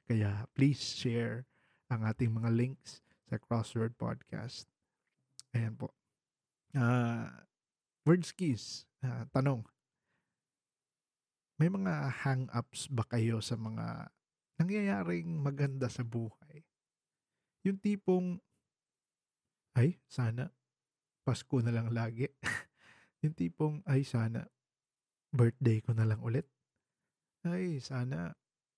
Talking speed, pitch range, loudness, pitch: 100 wpm, 115-150 Hz, -35 LUFS, 130 Hz